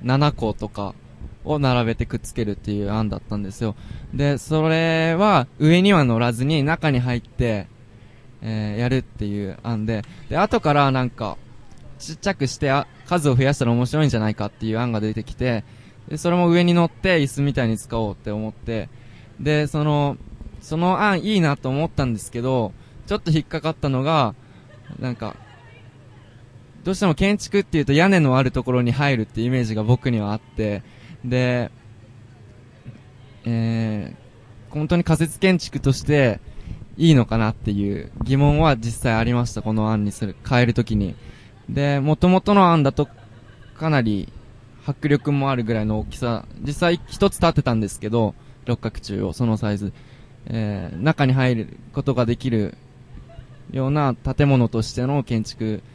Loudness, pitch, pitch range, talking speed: -21 LUFS, 125 Hz, 110-145 Hz, 315 characters per minute